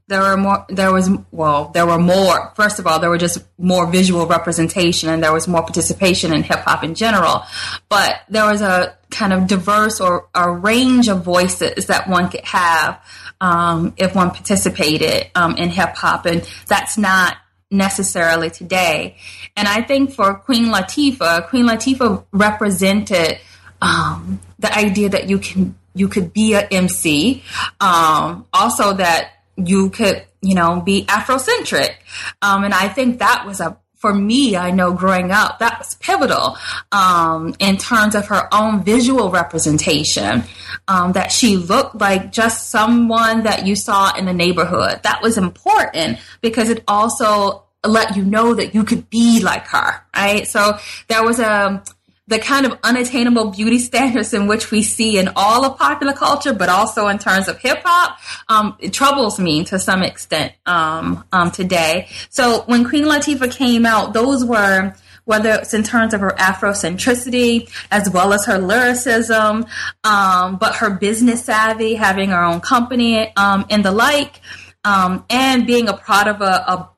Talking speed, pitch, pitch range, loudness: 170 wpm, 205 Hz, 185-230 Hz, -15 LUFS